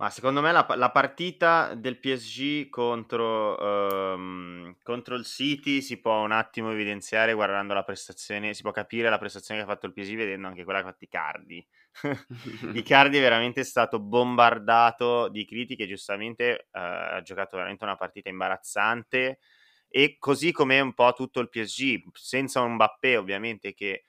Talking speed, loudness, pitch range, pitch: 160 wpm, -26 LUFS, 100-130 Hz, 115 Hz